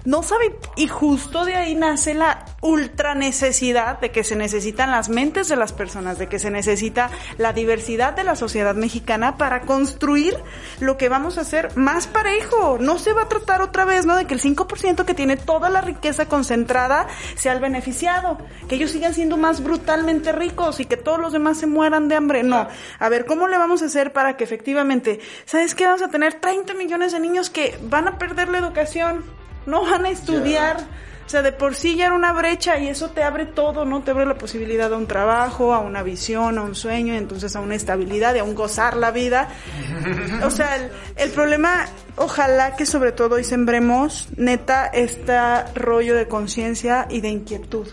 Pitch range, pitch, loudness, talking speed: 235-325 Hz, 275 Hz, -20 LUFS, 205 wpm